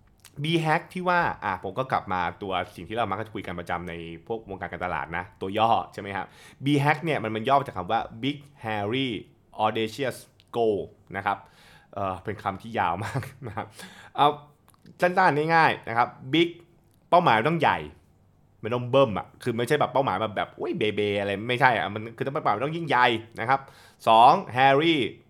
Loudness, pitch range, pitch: -25 LUFS, 100-140 Hz, 115 Hz